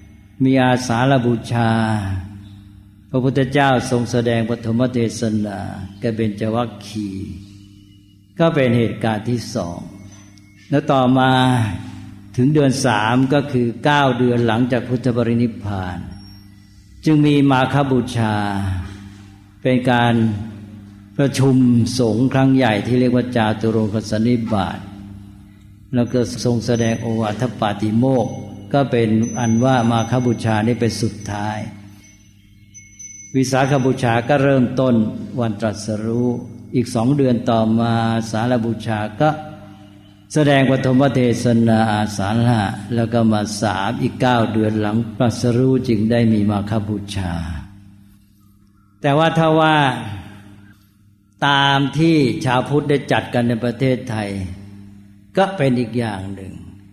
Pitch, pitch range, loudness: 115 Hz, 100-125 Hz, -18 LUFS